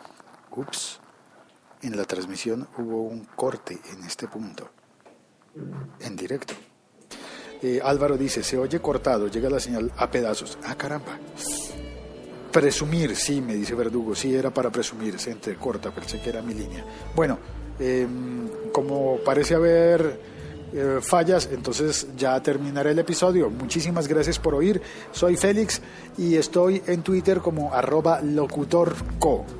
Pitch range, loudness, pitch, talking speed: 120-165 Hz, -24 LUFS, 140 Hz, 130 wpm